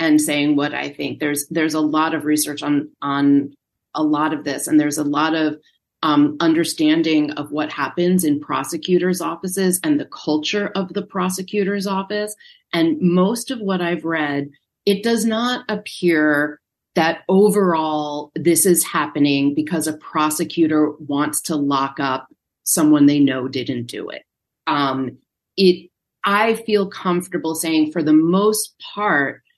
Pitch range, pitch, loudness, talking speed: 150-185 Hz, 160 Hz, -19 LUFS, 150 wpm